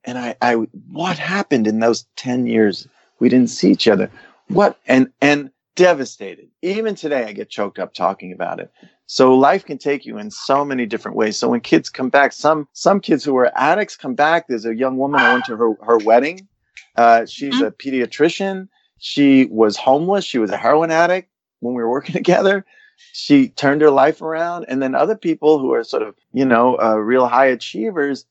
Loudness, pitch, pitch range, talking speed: -17 LUFS, 140 Hz, 120-180 Hz, 205 wpm